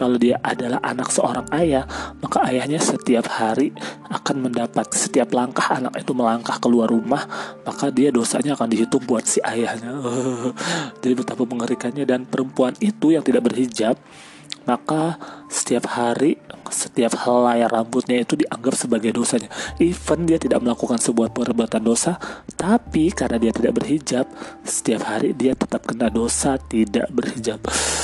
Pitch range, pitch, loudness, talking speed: 115-135 Hz, 125 Hz, -21 LUFS, 145 wpm